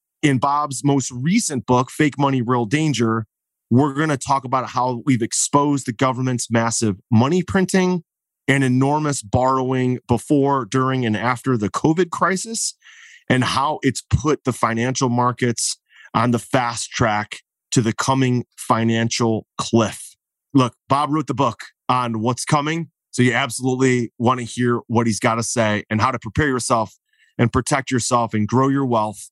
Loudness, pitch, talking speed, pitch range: -20 LUFS, 125 Hz, 160 wpm, 120-140 Hz